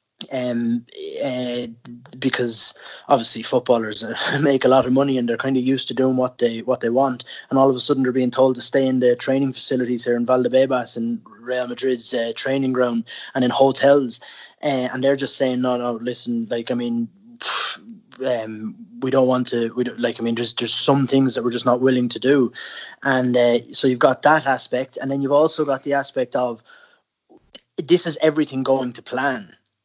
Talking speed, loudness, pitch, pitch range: 205 wpm, -20 LUFS, 130 Hz, 120-135 Hz